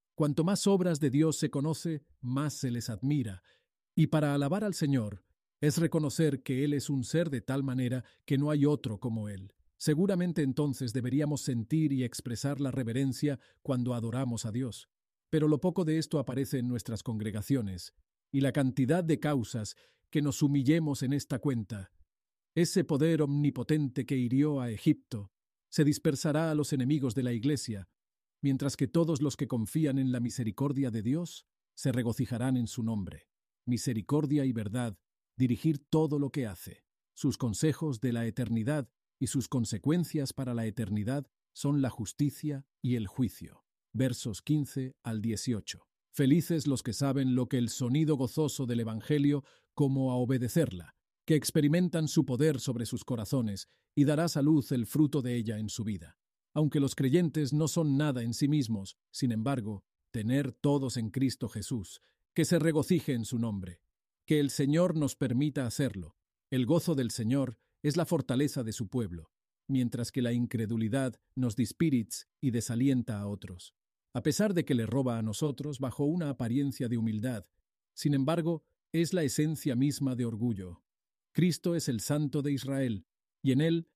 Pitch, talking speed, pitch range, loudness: 135 Hz, 165 wpm, 120-150 Hz, -31 LUFS